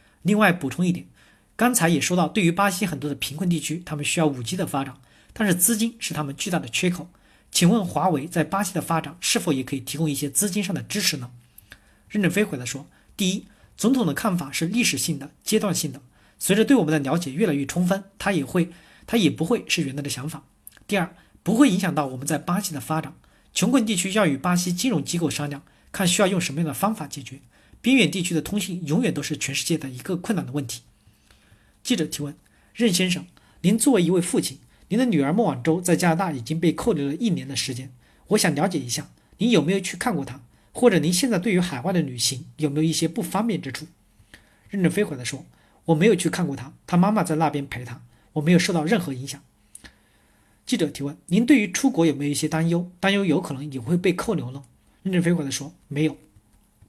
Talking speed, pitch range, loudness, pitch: 335 characters per minute, 145-195 Hz, -23 LUFS, 165 Hz